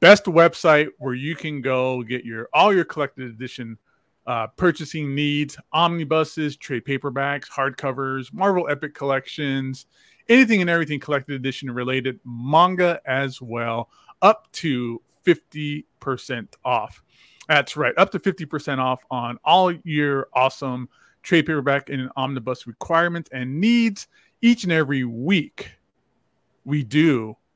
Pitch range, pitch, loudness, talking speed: 130-165 Hz, 140 Hz, -21 LUFS, 130 wpm